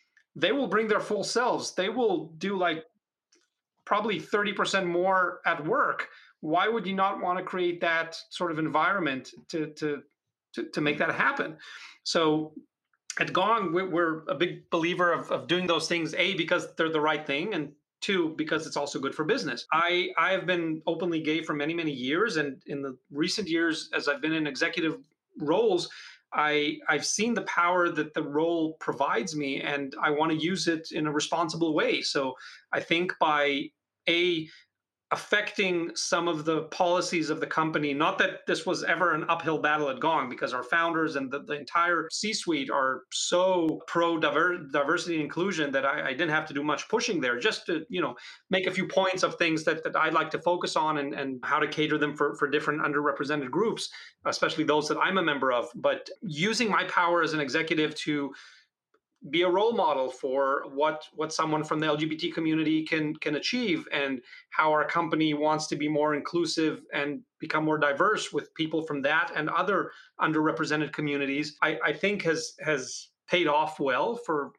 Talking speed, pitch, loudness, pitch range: 190 wpm, 160 Hz, -28 LUFS, 150-175 Hz